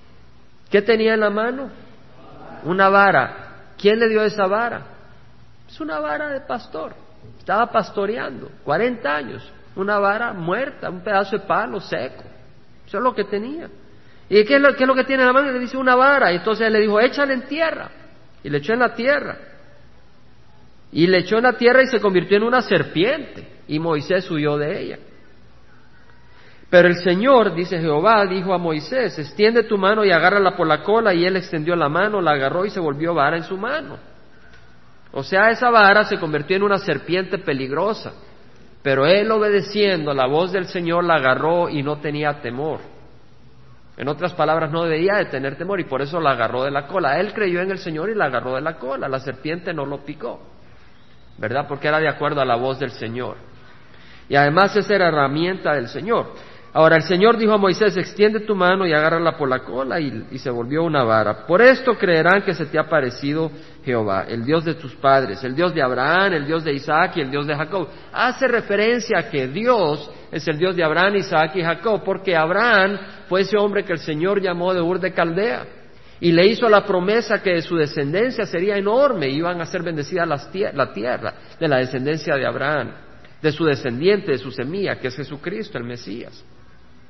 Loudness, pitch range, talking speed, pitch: -19 LUFS, 145-205 Hz, 200 wpm, 175 Hz